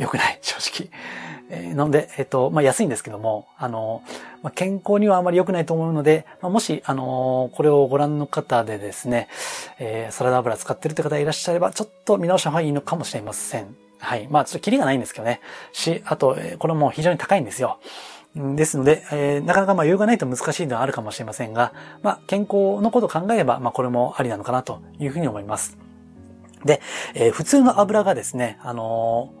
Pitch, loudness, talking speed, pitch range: 145 Hz, -21 LUFS, 445 characters per minute, 125-180 Hz